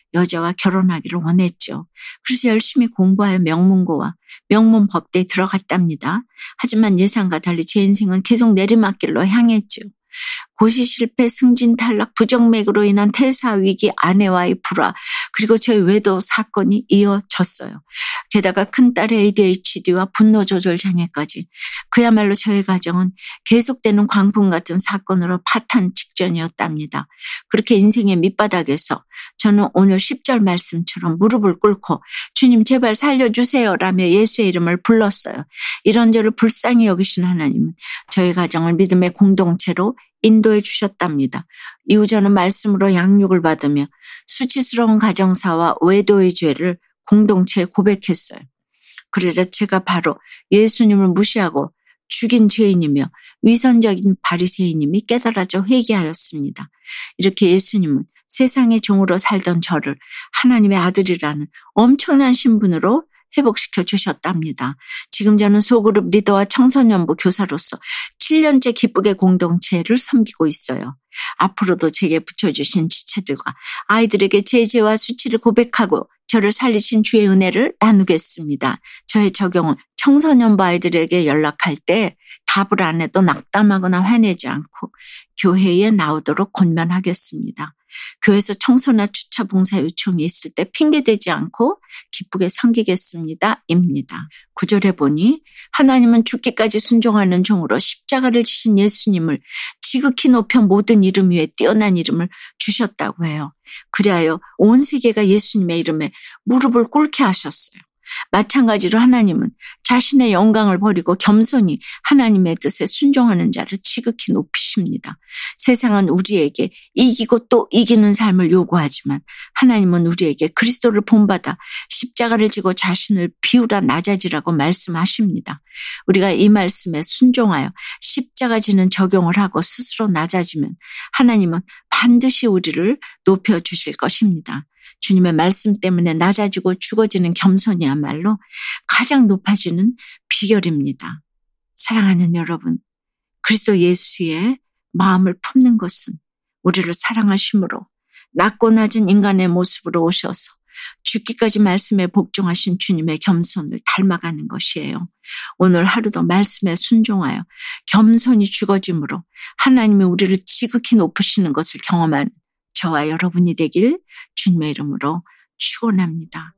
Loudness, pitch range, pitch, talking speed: -15 LUFS, 180-230 Hz, 200 Hz, 320 characters per minute